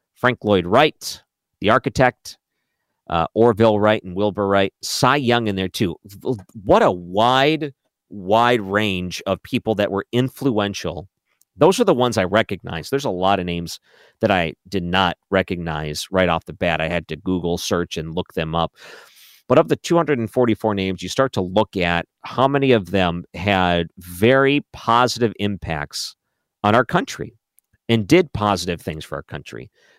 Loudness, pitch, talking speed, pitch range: -19 LUFS, 100 Hz, 165 wpm, 90-120 Hz